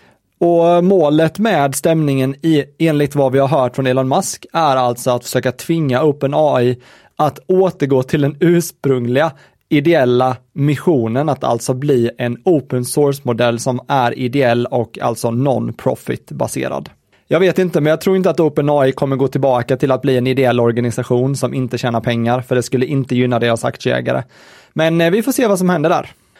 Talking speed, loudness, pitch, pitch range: 170 wpm, -15 LUFS, 135 Hz, 125-155 Hz